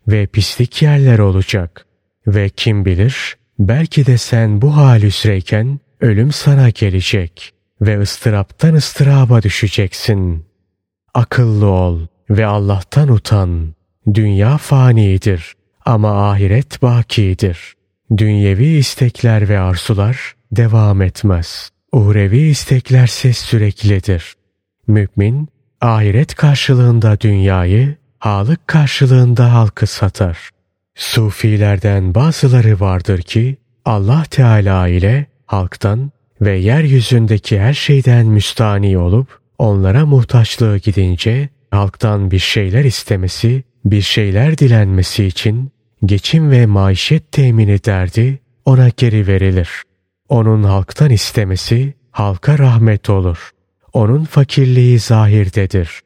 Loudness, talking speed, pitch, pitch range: -12 LUFS, 95 wpm, 110 Hz, 100-125 Hz